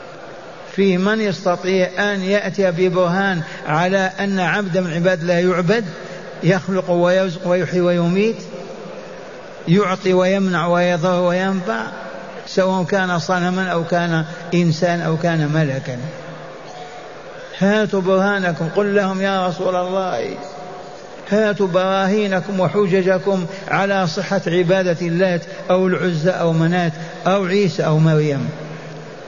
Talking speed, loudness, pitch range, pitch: 105 wpm, -18 LUFS, 175-195 Hz, 185 Hz